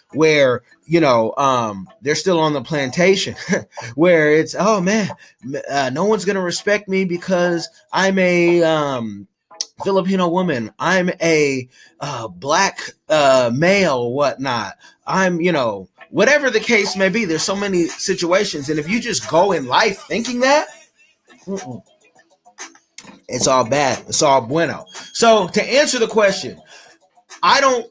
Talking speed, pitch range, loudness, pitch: 140 wpm, 155-205 Hz, -17 LUFS, 185 Hz